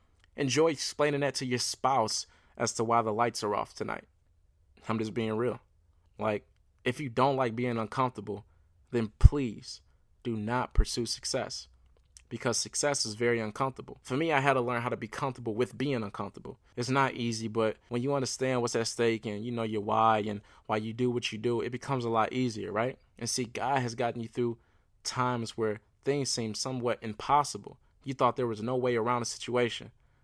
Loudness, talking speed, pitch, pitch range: -31 LUFS, 195 wpm, 115 Hz, 105-125 Hz